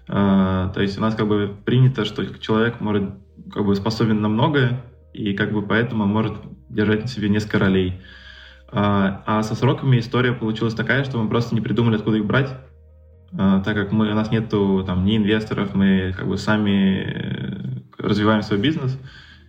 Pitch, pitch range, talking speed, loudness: 105 Hz, 95-110 Hz, 175 wpm, -20 LUFS